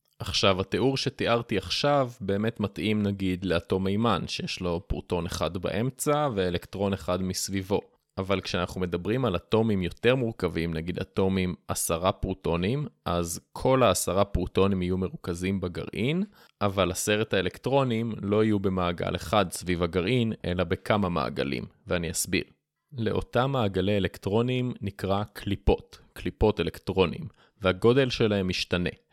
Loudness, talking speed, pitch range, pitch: -27 LUFS, 120 wpm, 90-115 Hz, 100 Hz